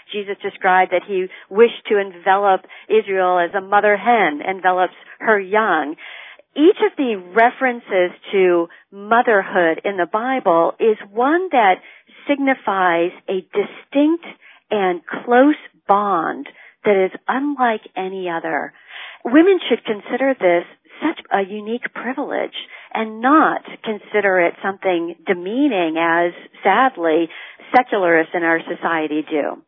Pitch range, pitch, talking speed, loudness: 180-250 Hz, 205 Hz, 120 wpm, -18 LUFS